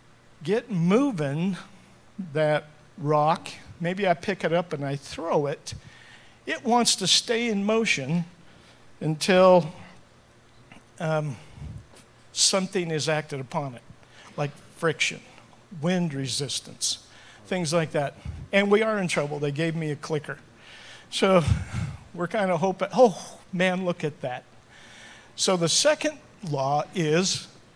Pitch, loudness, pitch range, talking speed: 160 Hz, -25 LUFS, 140-185 Hz, 125 wpm